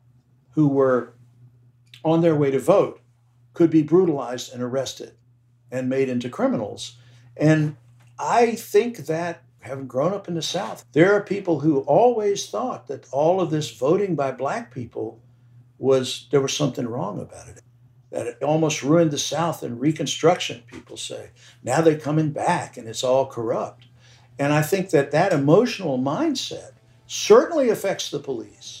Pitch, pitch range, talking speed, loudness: 135 Hz, 120-160 Hz, 160 wpm, -22 LUFS